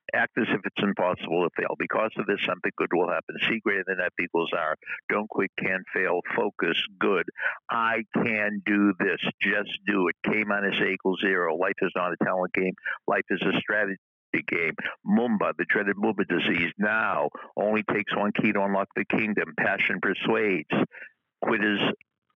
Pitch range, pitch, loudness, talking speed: 95-105 Hz, 100 Hz, -26 LUFS, 180 wpm